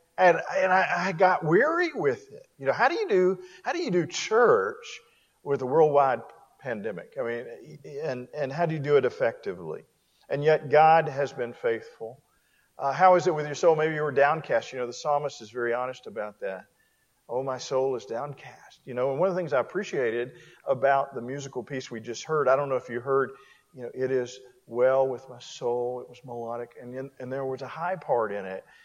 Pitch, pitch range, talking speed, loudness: 140 Hz, 130-185 Hz, 220 wpm, -26 LUFS